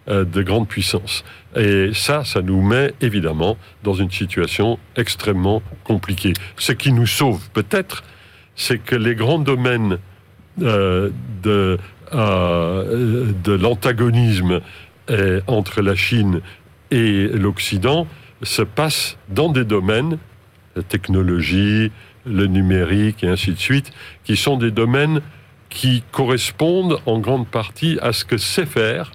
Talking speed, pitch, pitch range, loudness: 120 wpm, 105 Hz, 95-125 Hz, -18 LUFS